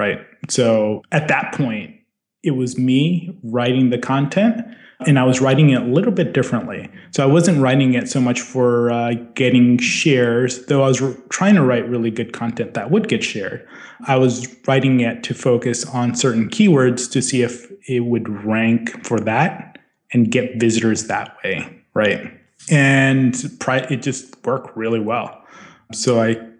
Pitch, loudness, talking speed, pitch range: 125 Hz, -17 LUFS, 175 wpm, 120-140 Hz